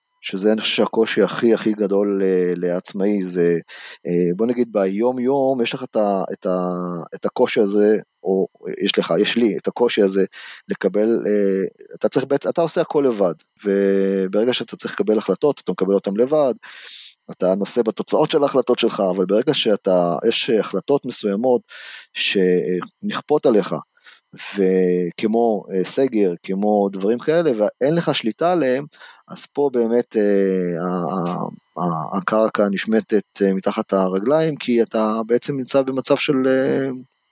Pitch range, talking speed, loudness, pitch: 95-125 Hz, 145 wpm, -19 LUFS, 105 Hz